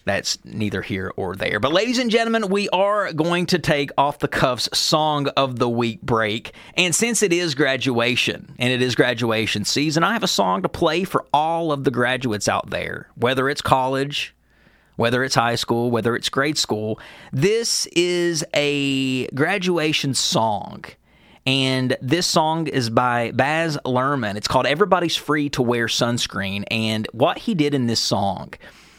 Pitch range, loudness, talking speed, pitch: 120-160 Hz, -20 LUFS, 170 wpm, 135 Hz